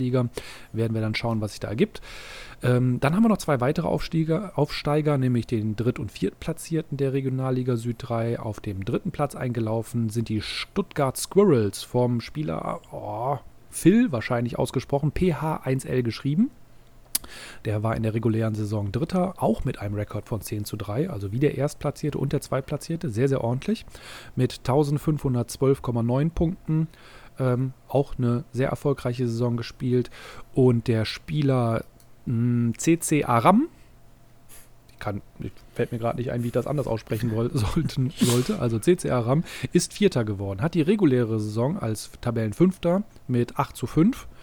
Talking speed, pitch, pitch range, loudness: 155 wpm, 125 Hz, 115-145 Hz, -25 LUFS